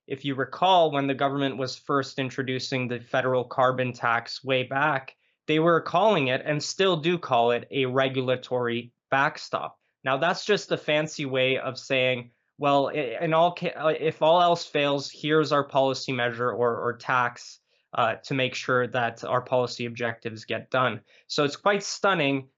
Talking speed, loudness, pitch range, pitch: 170 wpm, -25 LUFS, 125-150 Hz, 135 Hz